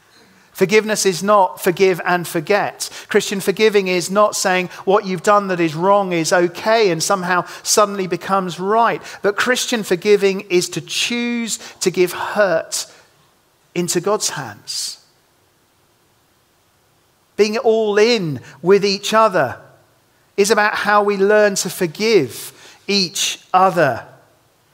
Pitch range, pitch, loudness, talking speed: 180-210 Hz, 200 Hz, -17 LUFS, 125 wpm